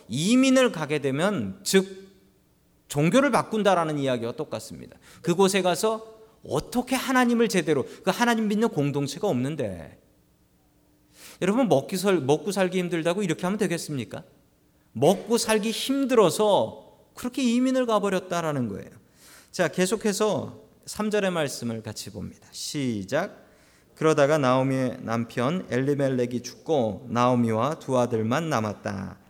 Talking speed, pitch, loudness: 300 characters per minute, 165 Hz, -25 LUFS